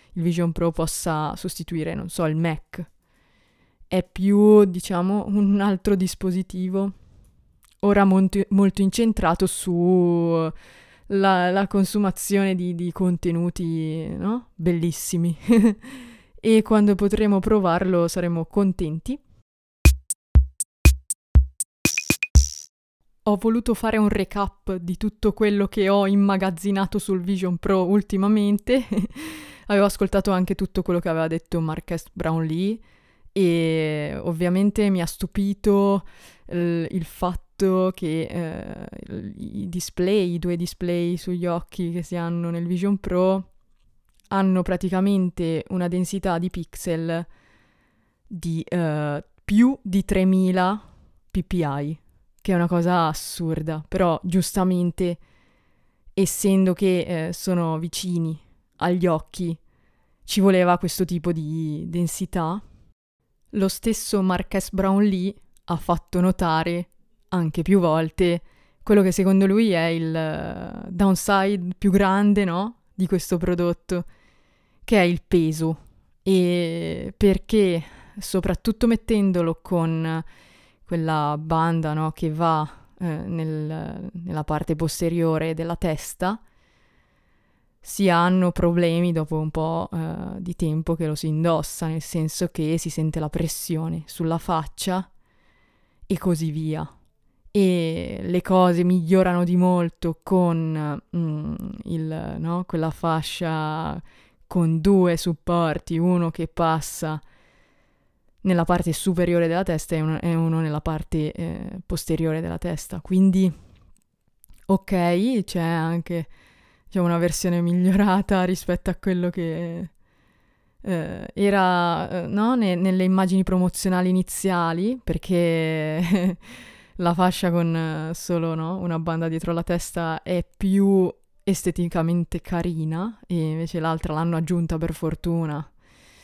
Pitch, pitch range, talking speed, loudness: 175 Hz, 165-190 Hz, 115 wpm, -23 LUFS